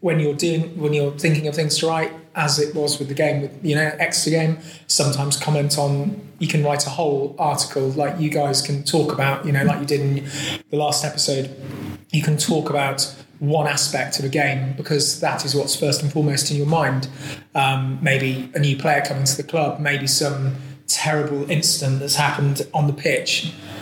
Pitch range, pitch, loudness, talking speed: 140-155 Hz, 145 Hz, -20 LUFS, 205 wpm